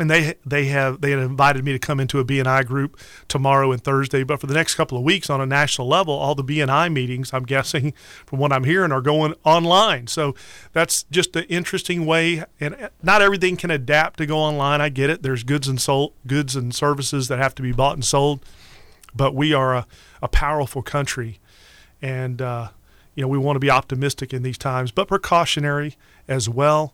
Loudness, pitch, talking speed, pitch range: -20 LUFS, 140 Hz, 210 wpm, 130-155 Hz